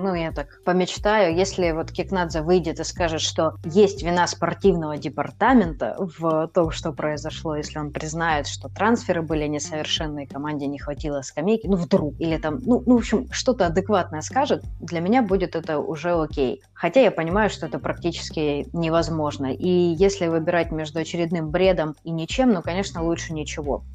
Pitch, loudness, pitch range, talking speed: 165 Hz, -23 LUFS, 155-185 Hz, 165 wpm